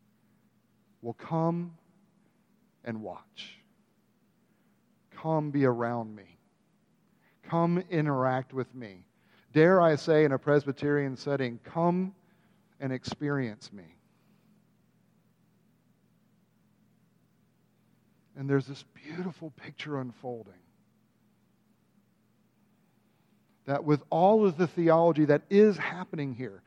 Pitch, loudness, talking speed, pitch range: 155 Hz, -28 LUFS, 90 wpm, 130-185 Hz